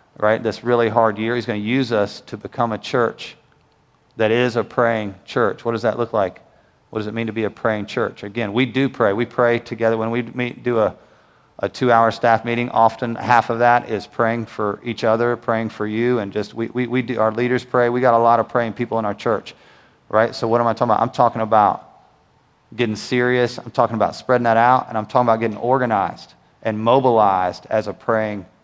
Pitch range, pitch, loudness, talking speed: 110-120 Hz, 115 Hz, -19 LUFS, 230 wpm